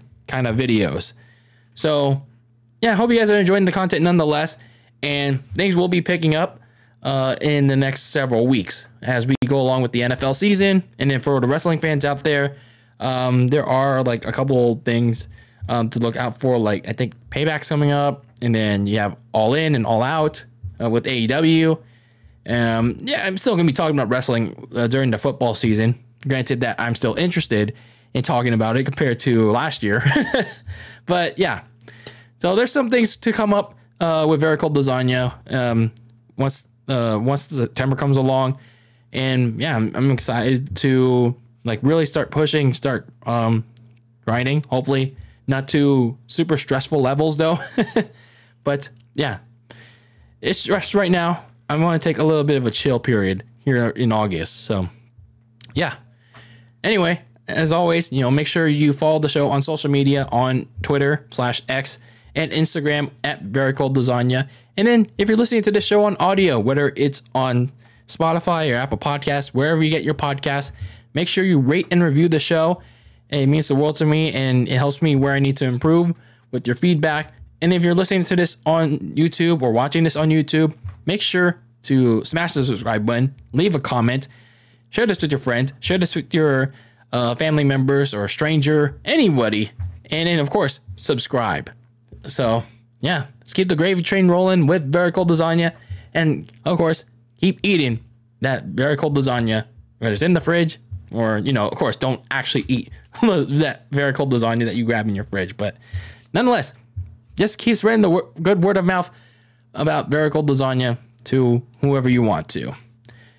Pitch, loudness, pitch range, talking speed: 135 Hz, -19 LUFS, 120-155 Hz, 180 wpm